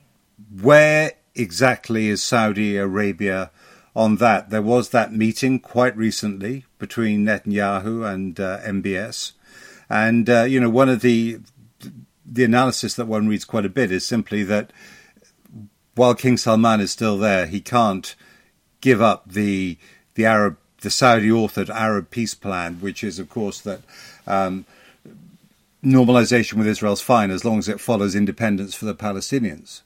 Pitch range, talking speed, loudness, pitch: 100-120 Hz, 150 wpm, -19 LUFS, 110 Hz